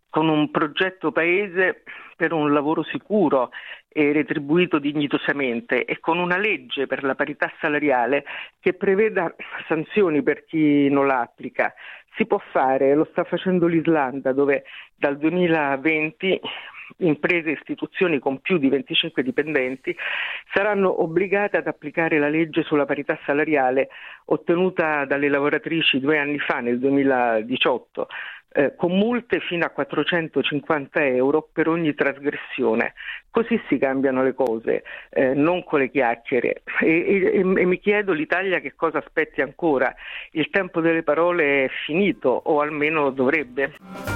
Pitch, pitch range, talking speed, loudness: 155 Hz, 140-175 Hz, 135 wpm, -21 LUFS